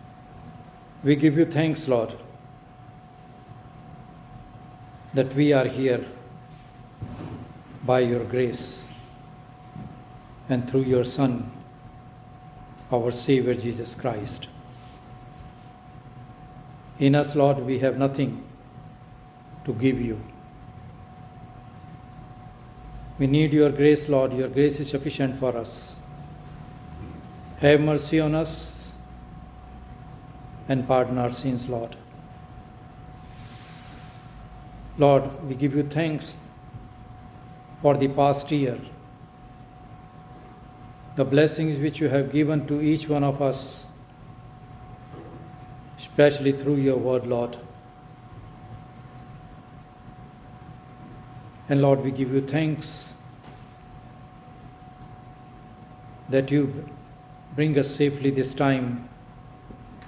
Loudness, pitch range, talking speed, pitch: -24 LUFS, 125-145 Hz, 85 wpm, 130 Hz